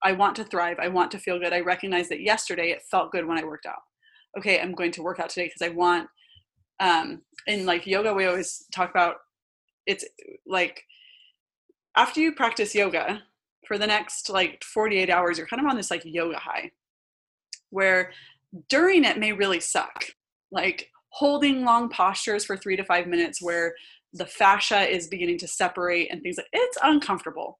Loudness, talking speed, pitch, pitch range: -24 LUFS, 185 wpm, 190 Hz, 175-225 Hz